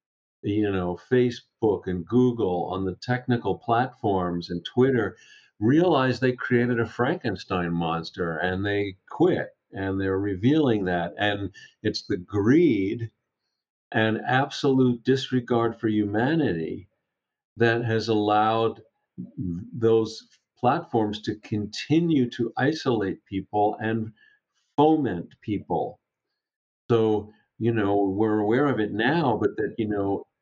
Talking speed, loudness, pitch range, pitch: 115 wpm, -25 LUFS, 95-125 Hz, 110 Hz